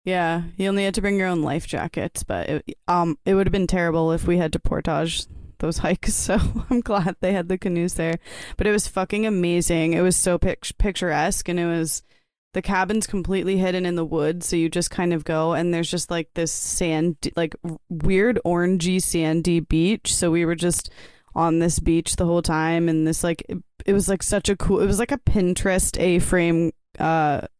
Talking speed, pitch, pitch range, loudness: 205 wpm, 175 Hz, 165-190 Hz, -22 LUFS